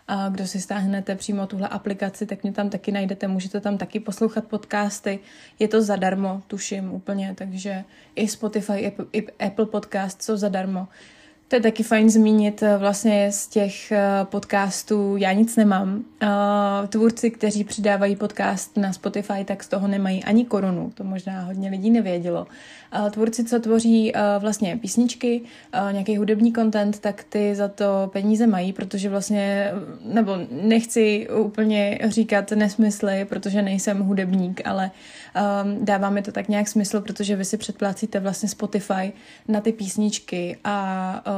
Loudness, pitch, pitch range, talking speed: -23 LUFS, 205 Hz, 195-215 Hz, 145 wpm